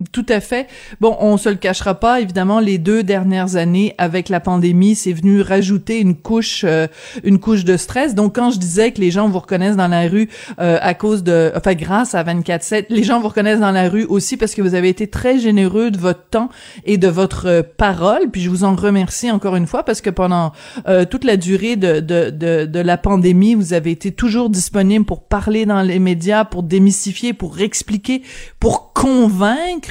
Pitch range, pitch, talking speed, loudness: 180-220 Hz, 200 Hz, 215 wpm, -15 LUFS